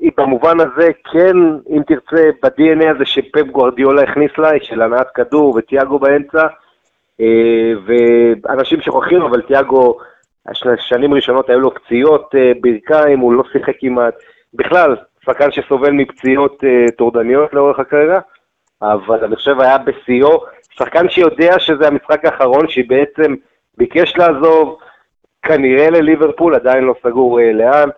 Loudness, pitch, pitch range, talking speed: -12 LUFS, 140 Hz, 125-155 Hz, 120 wpm